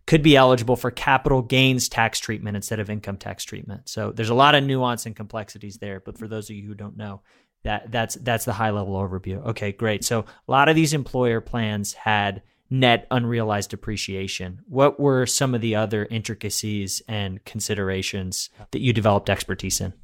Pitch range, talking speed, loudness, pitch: 100-125 Hz, 190 wpm, -22 LUFS, 110 Hz